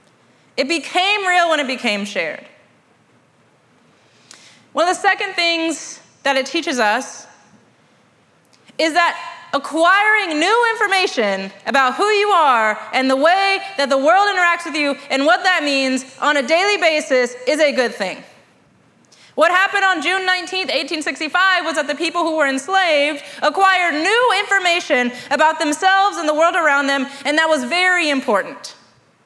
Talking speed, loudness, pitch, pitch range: 150 wpm, -16 LUFS, 325 Hz, 280-370 Hz